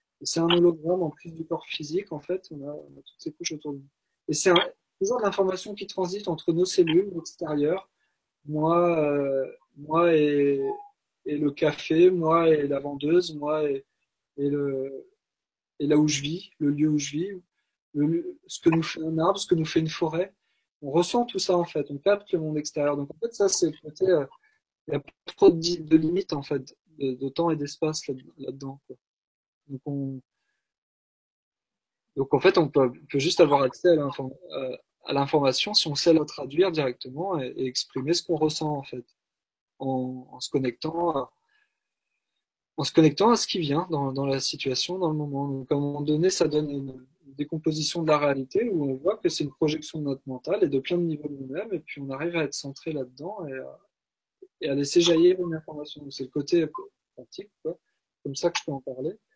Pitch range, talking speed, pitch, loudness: 140-175 Hz, 215 wpm, 155 Hz, -26 LUFS